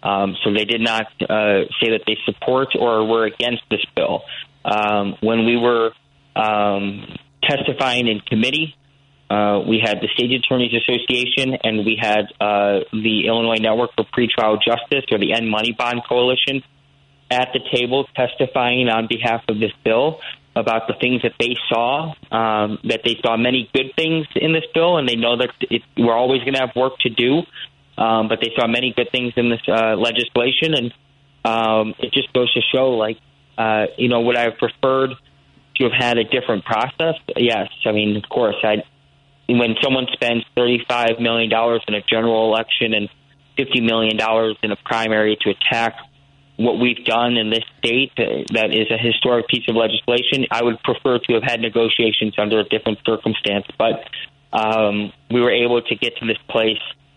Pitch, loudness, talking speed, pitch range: 115 Hz, -18 LUFS, 185 wpm, 110-125 Hz